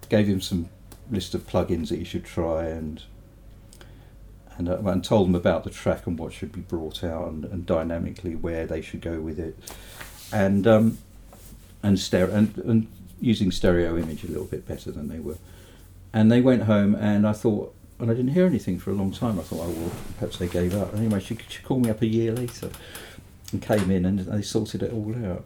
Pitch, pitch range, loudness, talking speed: 95 Hz, 90-110 Hz, -25 LUFS, 220 wpm